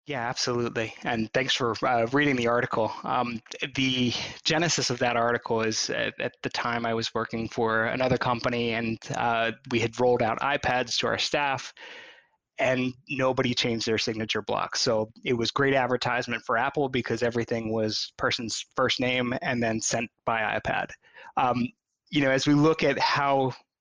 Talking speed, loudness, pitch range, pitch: 170 wpm, -26 LUFS, 115-135 Hz, 120 Hz